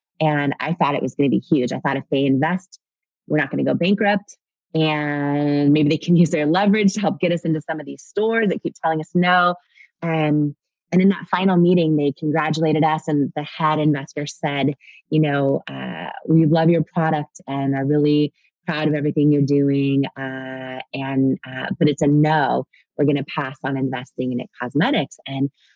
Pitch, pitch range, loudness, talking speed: 150 Hz, 140-165 Hz, -20 LUFS, 205 wpm